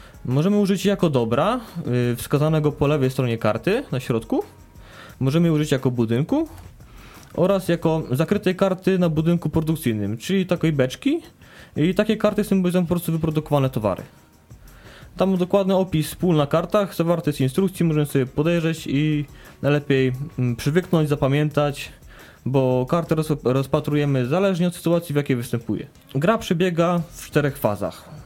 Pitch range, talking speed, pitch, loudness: 135-180 Hz, 135 wpm, 155 Hz, -21 LUFS